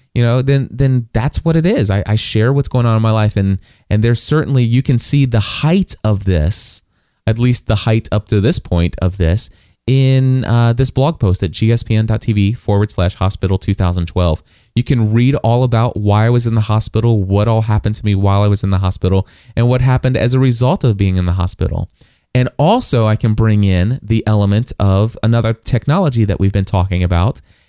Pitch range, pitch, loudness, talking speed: 100-125 Hz, 110 Hz, -14 LUFS, 210 wpm